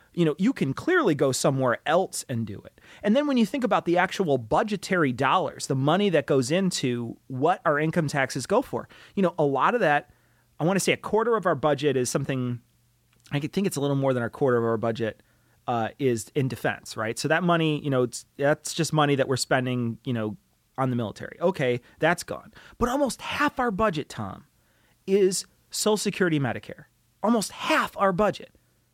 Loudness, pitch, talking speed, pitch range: -25 LUFS, 145 Hz, 205 wpm, 125-185 Hz